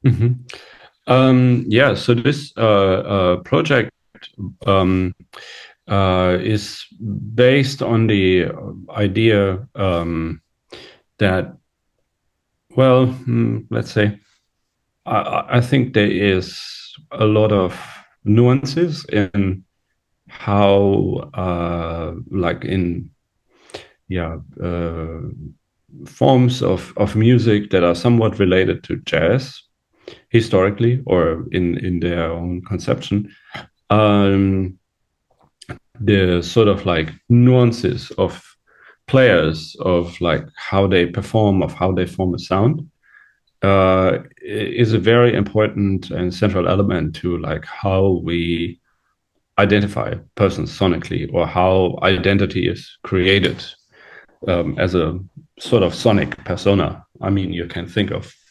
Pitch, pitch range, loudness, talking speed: 100 Hz, 90-115 Hz, -17 LUFS, 110 wpm